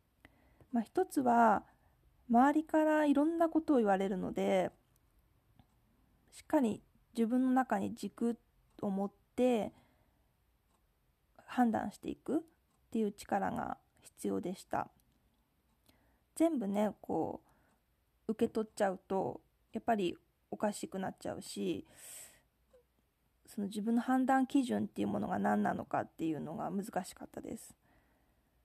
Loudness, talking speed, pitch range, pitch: -35 LUFS, 235 characters per minute, 205-270 Hz, 230 Hz